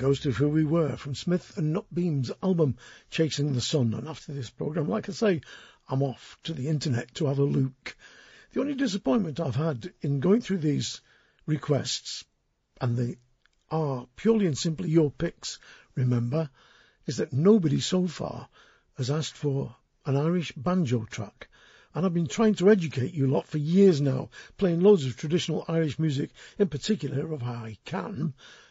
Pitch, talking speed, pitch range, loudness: 155 Hz, 175 wpm, 135-175 Hz, -27 LUFS